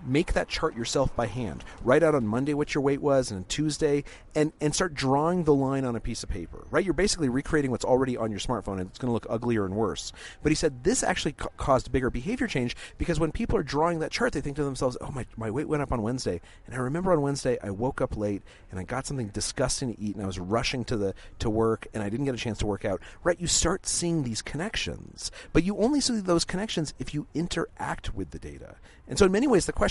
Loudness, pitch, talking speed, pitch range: -28 LUFS, 130 Hz, 265 wpm, 110-150 Hz